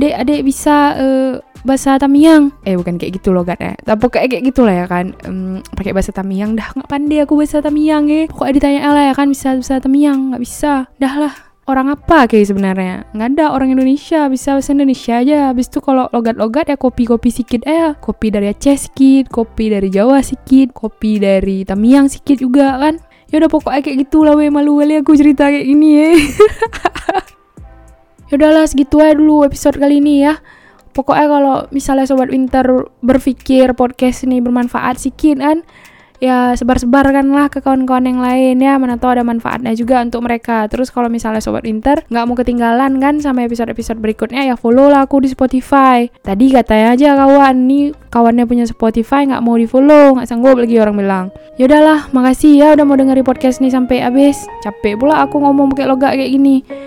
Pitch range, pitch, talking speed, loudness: 240-285 Hz, 265 Hz, 190 wpm, -11 LUFS